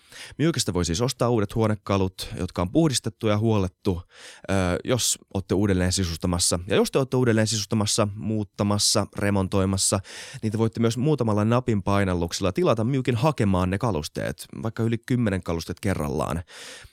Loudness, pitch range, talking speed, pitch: -24 LUFS, 95-115 Hz, 140 wpm, 105 Hz